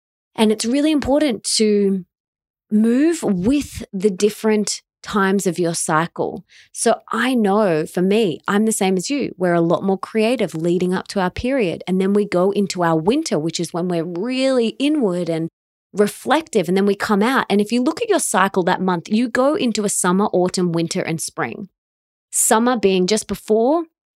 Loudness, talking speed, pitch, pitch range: -18 LUFS, 185 wpm, 205 Hz, 180-230 Hz